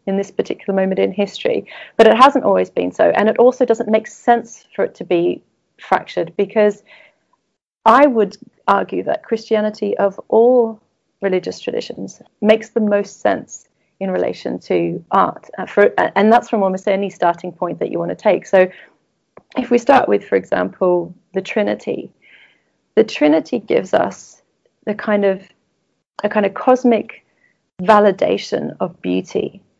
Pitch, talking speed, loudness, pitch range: 210 Hz, 155 wpm, -16 LUFS, 190-235 Hz